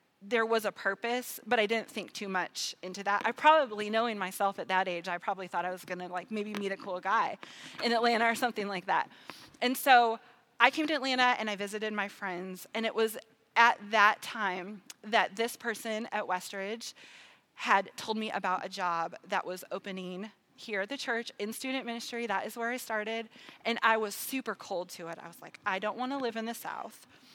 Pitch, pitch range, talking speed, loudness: 215 Hz, 195-235 Hz, 215 wpm, -31 LUFS